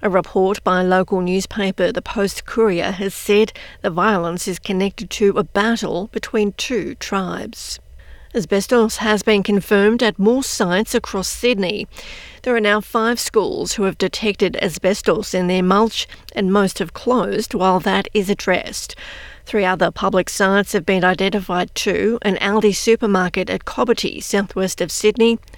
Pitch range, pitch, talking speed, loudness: 190-220 Hz, 200 Hz, 155 wpm, -18 LUFS